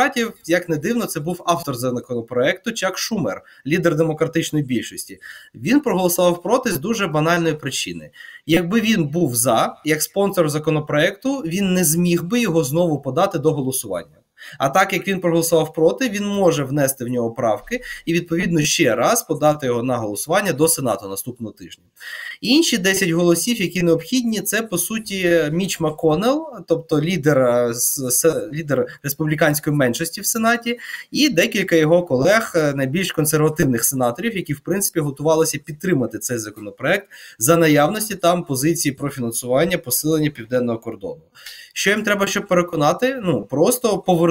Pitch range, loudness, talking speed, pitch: 145-190 Hz, -19 LUFS, 145 wpm, 165 Hz